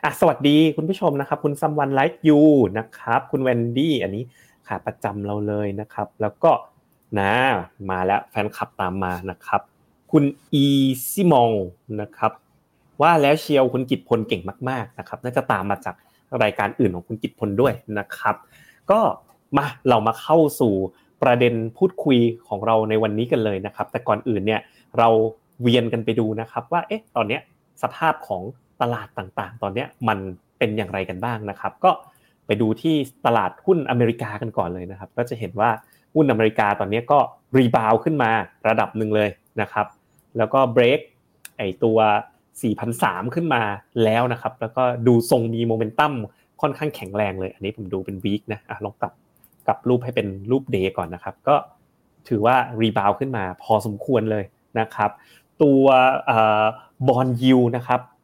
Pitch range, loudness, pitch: 105-130 Hz, -21 LUFS, 115 Hz